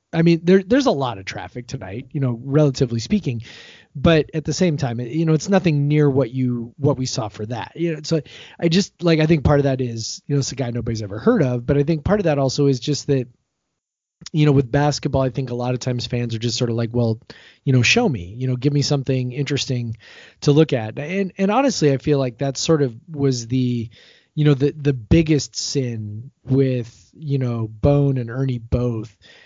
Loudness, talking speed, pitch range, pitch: -20 LUFS, 235 wpm, 120-150 Hz, 135 Hz